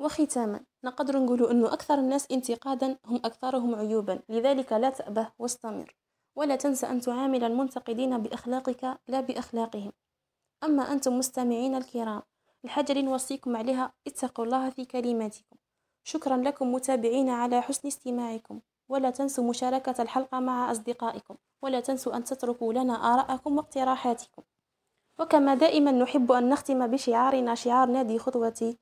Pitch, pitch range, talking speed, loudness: 255 Hz, 240-270 Hz, 125 wpm, -28 LUFS